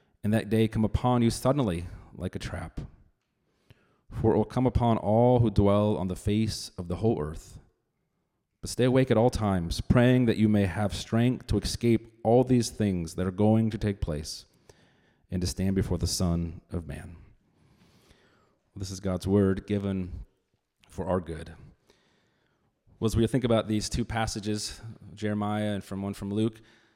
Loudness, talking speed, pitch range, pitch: -27 LUFS, 175 wpm, 95-115 Hz, 105 Hz